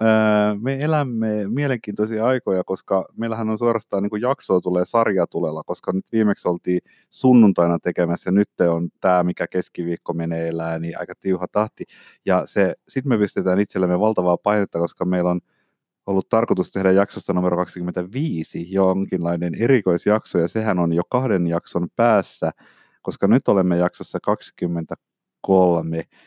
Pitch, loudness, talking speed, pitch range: 95 Hz, -21 LUFS, 135 wpm, 90-105 Hz